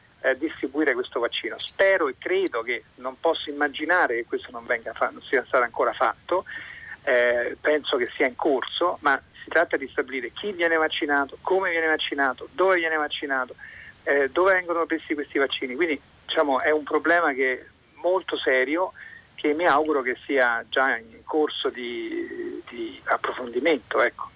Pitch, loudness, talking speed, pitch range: 165 Hz, -24 LUFS, 165 wpm, 150-210 Hz